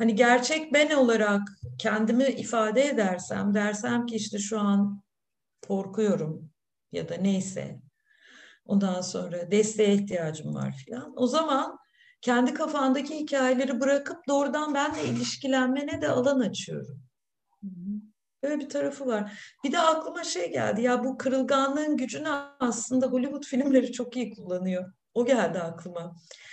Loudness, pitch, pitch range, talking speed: -27 LUFS, 245 Hz, 200-275 Hz, 125 wpm